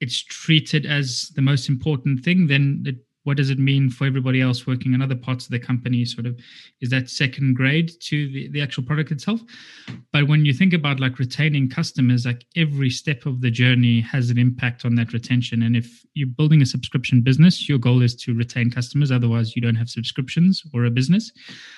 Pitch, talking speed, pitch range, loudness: 130 Hz, 210 wpm, 125-150 Hz, -20 LUFS